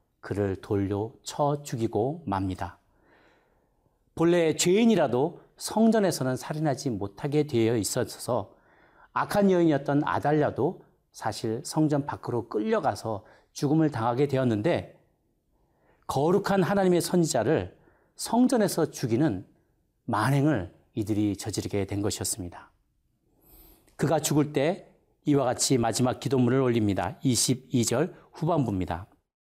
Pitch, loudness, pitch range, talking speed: 135 Hz, -27 LUFS, 110-155 Hz, 265 characters per minute